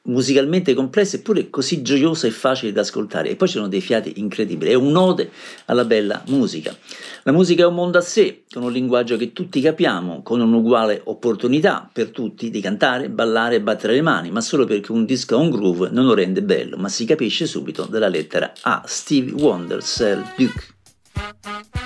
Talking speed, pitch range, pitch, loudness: 190 wpm, 115-175 Hz, 130 Hz, -19 LUFS